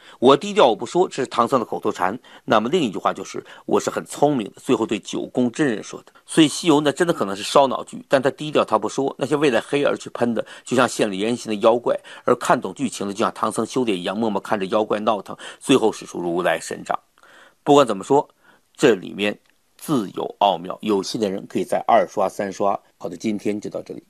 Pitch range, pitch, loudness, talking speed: 110-145 Hz, 125 Hz, -21 LUFS, 340 characters per minute